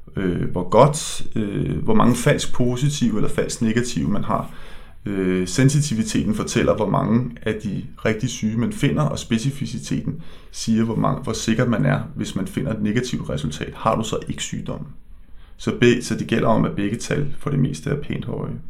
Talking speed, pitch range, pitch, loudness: 190 wpm, 80-120 Hz, 110 Hz, -22 LUFS